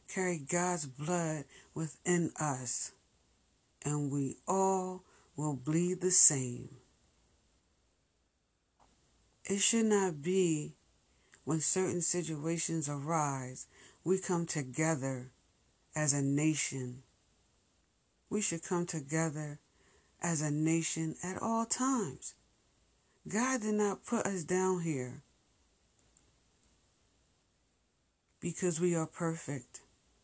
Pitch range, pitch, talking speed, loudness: 135-180 Hz, 160 Hz, 95 wpm, -33 LUFS